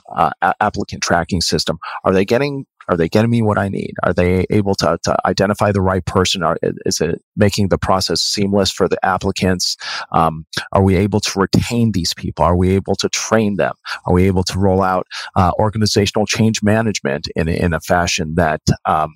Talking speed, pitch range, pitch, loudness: 200 wpm, 90-105 Hz, 95 Hz, -16 LUFS